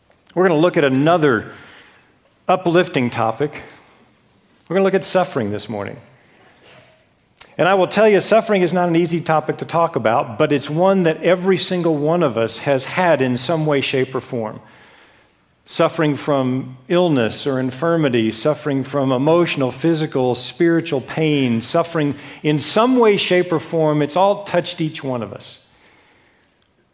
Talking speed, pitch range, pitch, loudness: 160 wpm, 130-175 Hz, 150 Hz, -18 LUFS